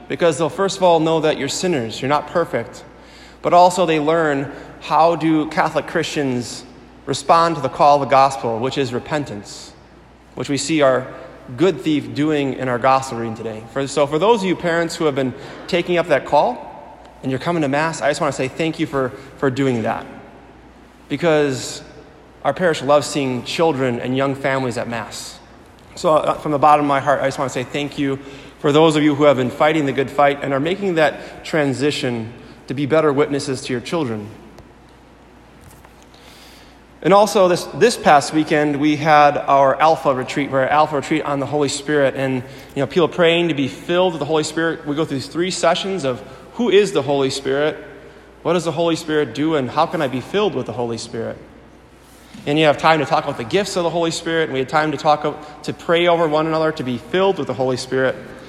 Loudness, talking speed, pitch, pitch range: -18 LUFS, 215 wpm, 145 Hz, 135-160 Hz